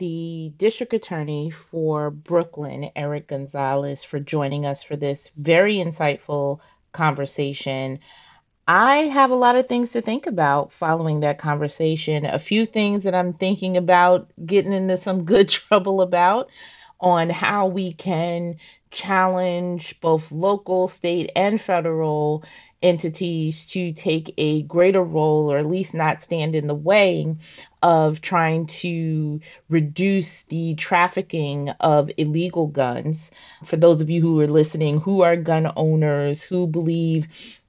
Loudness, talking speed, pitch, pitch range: -21 LUFS, 135 wpm, 165 Hz, 150-185 Hz